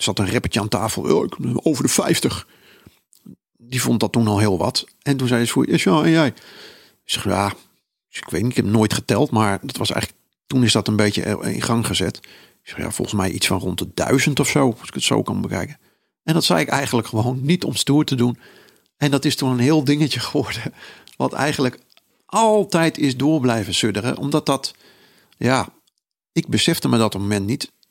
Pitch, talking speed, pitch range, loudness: 125 Hz, 220 wpm, 110-145 Hz, -19 LUFS